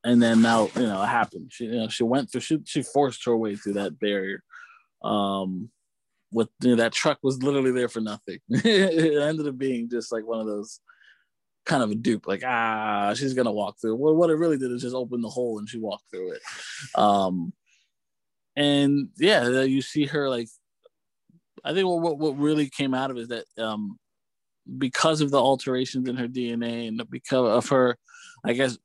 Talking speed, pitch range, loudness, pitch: 205 wpm, 115-150 Hz, -25 LUFS, 125 Hz